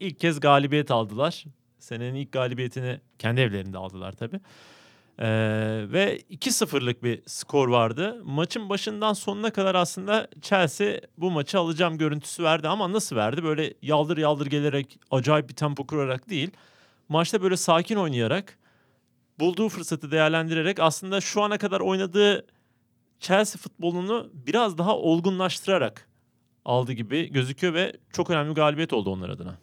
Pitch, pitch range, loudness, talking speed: 160 Hz, 130-190 Hz, -25 LUFS, 140 wpm